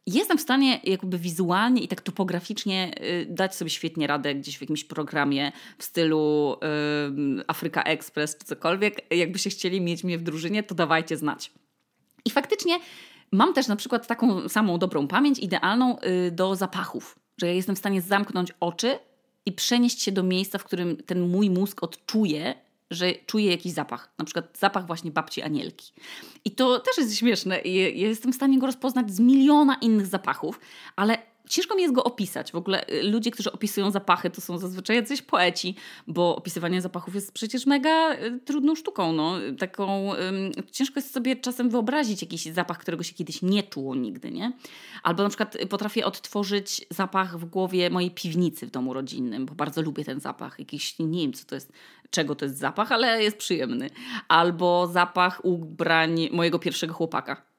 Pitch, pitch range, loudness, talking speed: 190 Hz, 170-235 Hz, -25 LUFS, 175 wpm